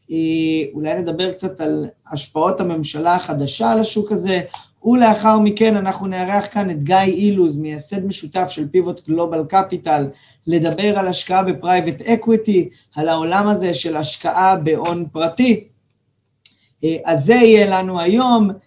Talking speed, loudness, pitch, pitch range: 130 wpm, -17 LUFS, 180 Hz, 155-195 Hz